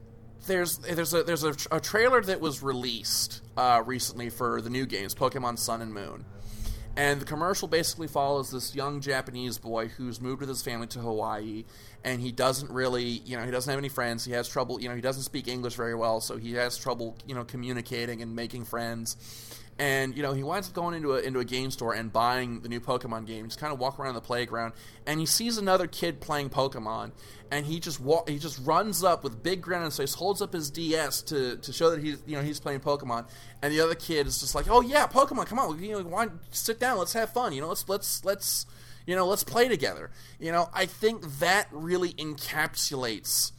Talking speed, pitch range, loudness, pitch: 230 wpm, 120-160 Hz, -29 LUFS, 135 Hz